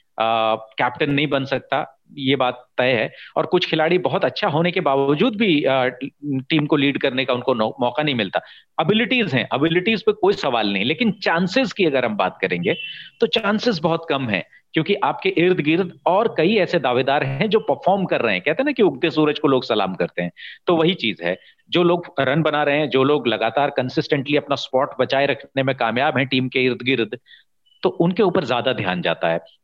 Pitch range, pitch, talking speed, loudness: 130-175 Hz, 145 Hz, 210 wpm, -20 LUFS